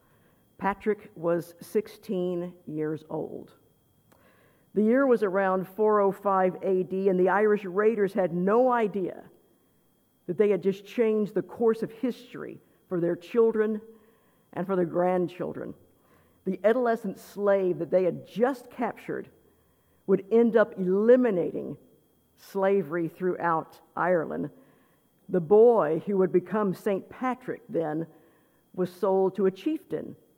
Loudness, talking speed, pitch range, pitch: -27 LUFS, 120 wpm, 180-215 Hz, 195 Hz